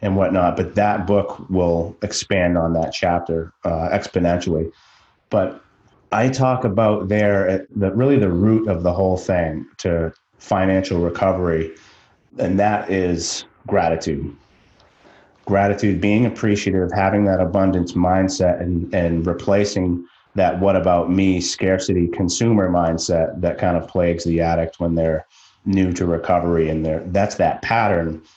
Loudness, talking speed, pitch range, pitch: -19 LUFS, 140 wpm, 85-100 Hz, 95 Hz